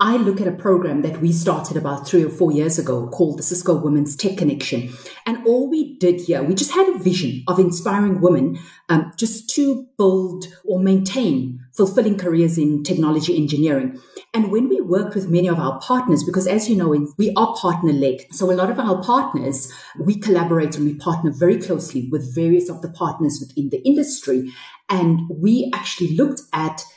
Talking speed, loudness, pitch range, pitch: 190 wpm, -19 LUFS, 155-200 Hz, 175 Hz